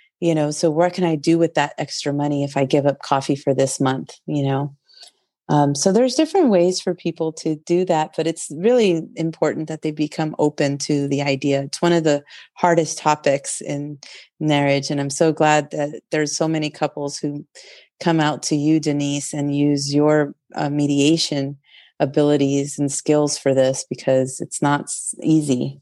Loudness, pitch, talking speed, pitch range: -20 LUFS, 150 Hz, 185 wpm, 145-160 Hz